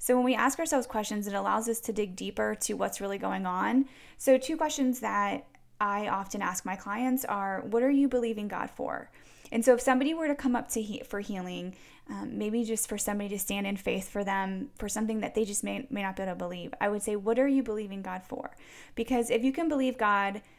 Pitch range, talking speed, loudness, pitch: 200-255 Hz, 240 wpm, -30 LUFS, 220 Hz